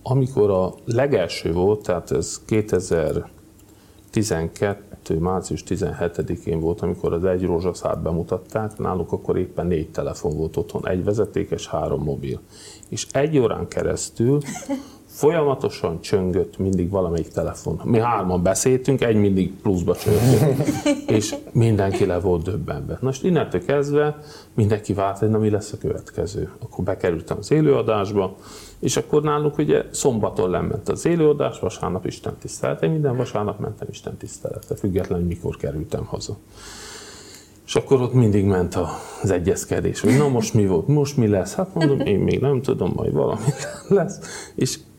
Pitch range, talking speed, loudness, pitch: 95-140 Hz, 145 wpm, -22 LUFS, 105 Hz